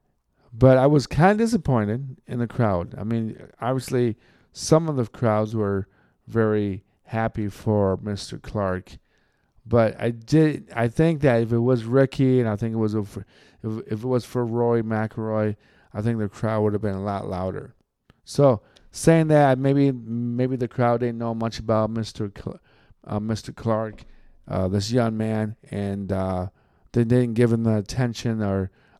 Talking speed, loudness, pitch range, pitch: 175 wpm, -23 LUFS, 105-125 Hz, 115 Hz